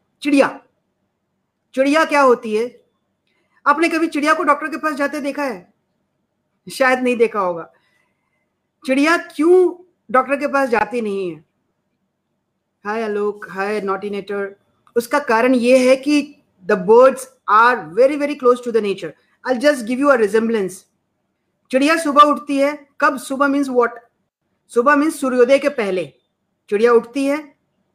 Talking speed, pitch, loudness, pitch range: 140 wpm, 260 Hz, -17 LUFS, 220-290 Hz